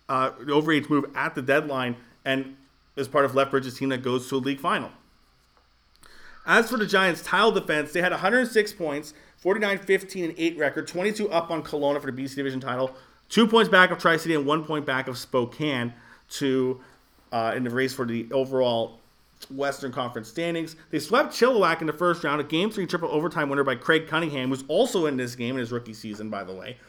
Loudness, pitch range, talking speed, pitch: -25 LUFS, 130-170 Hz, 210 wpm, 145 Hz